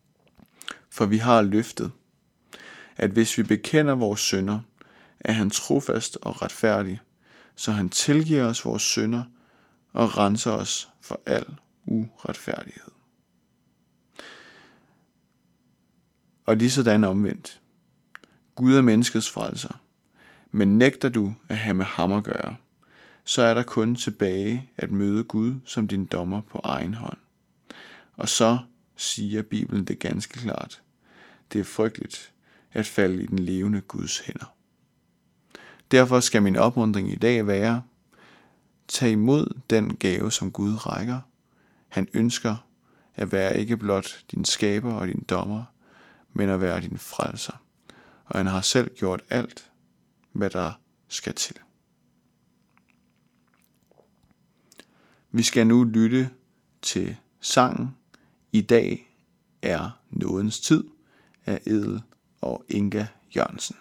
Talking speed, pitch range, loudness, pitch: 125 wpm, 100-115 Hz, -24 LUFS, 110 Hz